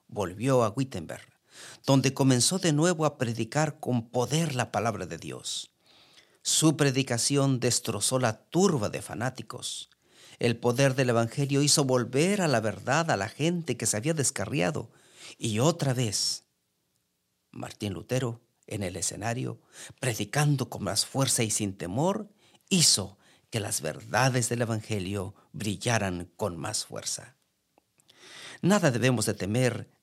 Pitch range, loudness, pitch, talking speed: 105-140 Hz, -27 LUFS, 125 Hz, 135 wpm